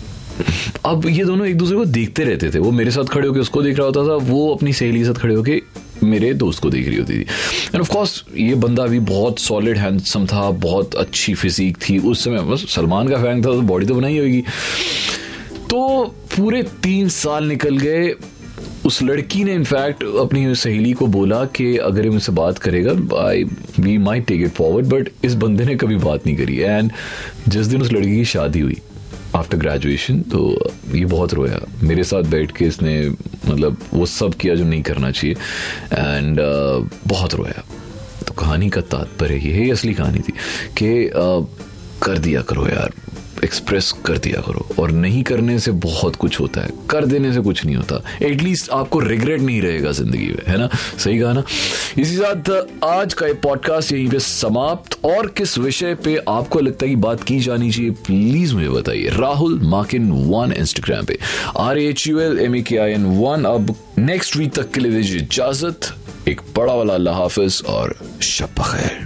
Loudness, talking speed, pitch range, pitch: -17 LUFS, 190 wpm, 95-140 Hz, 115 Hz